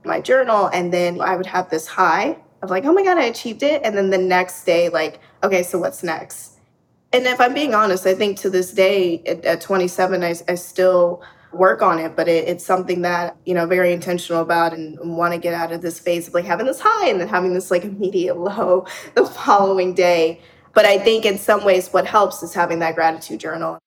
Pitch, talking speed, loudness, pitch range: 180 Hz, 230 wpm, -18 LUFS, 170-195 Hz